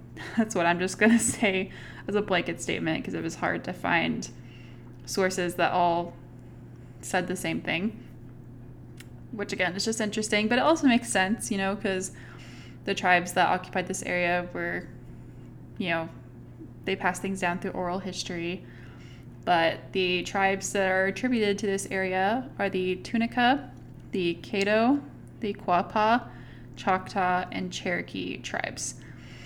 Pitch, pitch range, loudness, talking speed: 185 Hz, 170-205 Hz, -27 LUFS, 150 wpm